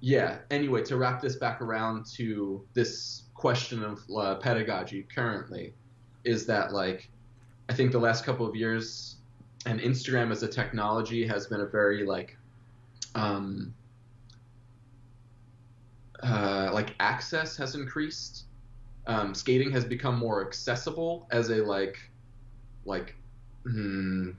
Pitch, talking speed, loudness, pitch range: 120 Hz, 125 wpm, -30 LUFS, 110-120 Hz